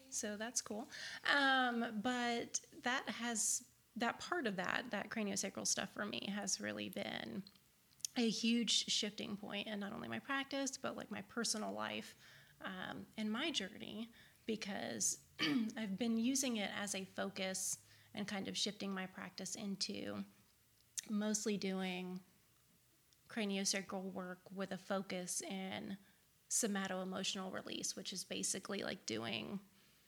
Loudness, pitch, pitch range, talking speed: -41 LUFS, 205 Hz, 190-225 Hz, 135 wpm